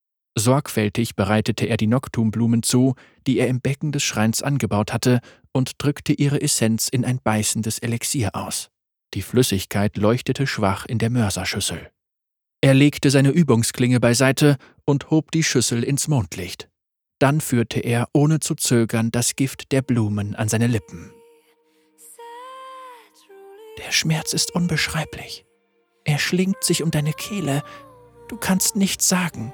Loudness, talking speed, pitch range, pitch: -20 LUFS, 140 wpm, 115-155 Hz, 130 Hz